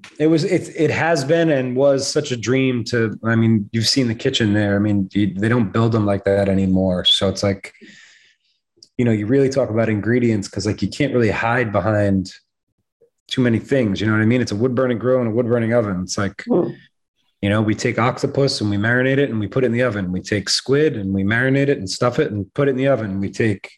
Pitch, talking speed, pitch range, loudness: 115 Hz, 250 wpm, 105-130 Hz, -18 LUFS